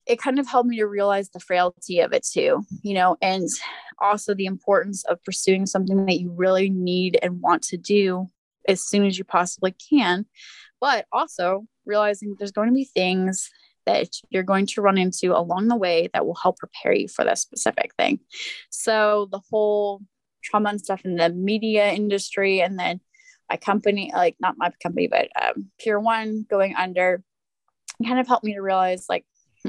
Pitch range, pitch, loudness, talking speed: 185-220 Hz, 200 Hz, -22 LUFS, 190 wpm